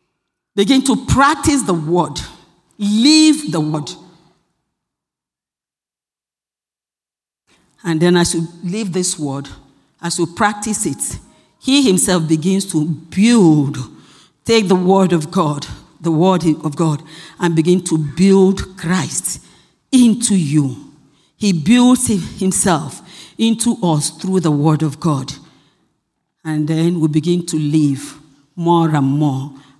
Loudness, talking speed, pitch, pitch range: -15 LUFS, 120 wpm, 170 Hz, 155-190 Hz